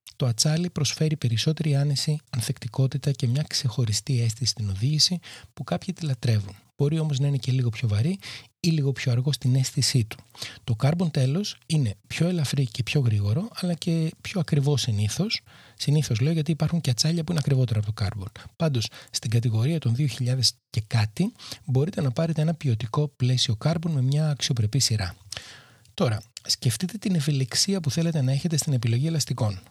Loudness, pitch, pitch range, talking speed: -25 LUFS, 135 Hz, 120-155 Hz, 175 wpm